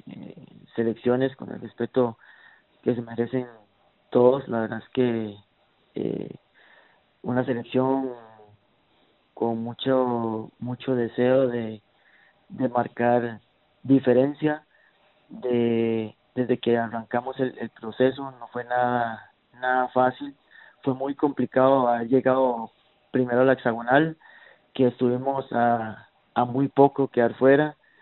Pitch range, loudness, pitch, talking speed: 115-130 Hz, -24 LUFS, 125 Hz, 115 wpm